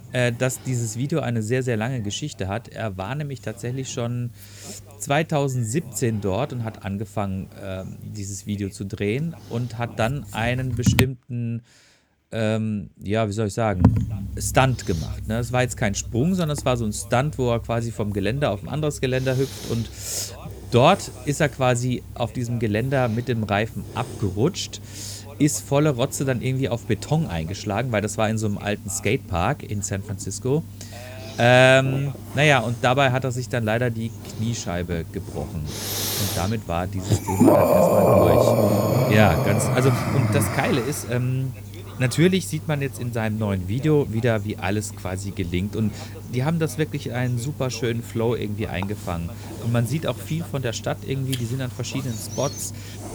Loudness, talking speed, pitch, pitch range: -23 LUFS, 175 wpm, 115 Hz, 105-130 Hz